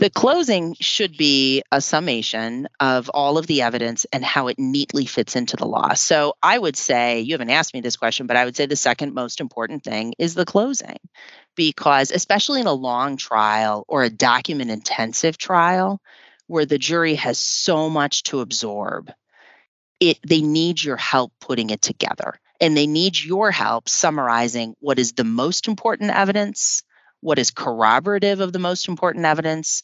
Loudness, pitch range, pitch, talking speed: -19 LUFS, 125-180 Hz, 150 Hz, 175 wpm